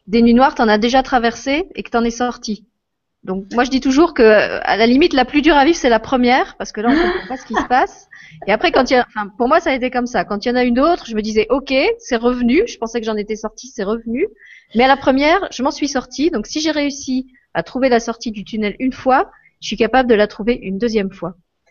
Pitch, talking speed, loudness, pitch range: 250 Hz, 295 wpm, -16 LUFS, 220-280 Hz